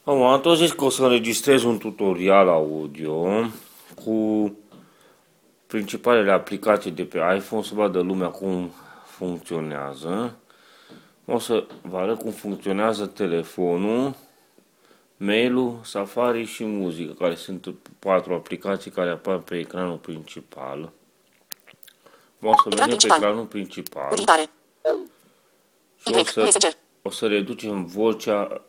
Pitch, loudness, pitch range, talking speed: 100 Hz, -22 LUFS, 90-115 Hz, 115 wpm